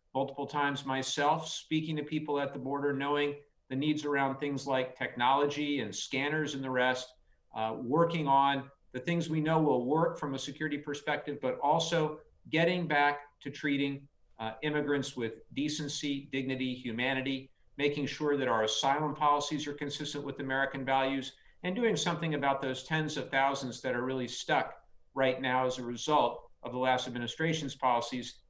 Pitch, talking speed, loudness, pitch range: 140 Hz, 165 wpm, -32 LUFS, 130-150 Hz